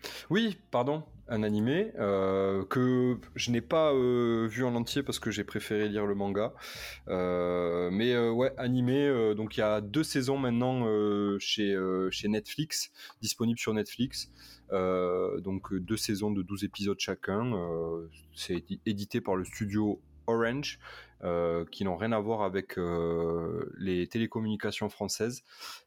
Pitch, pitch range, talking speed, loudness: 105 Hz, 95-120 Hz, 155 wpm, -31 LUFS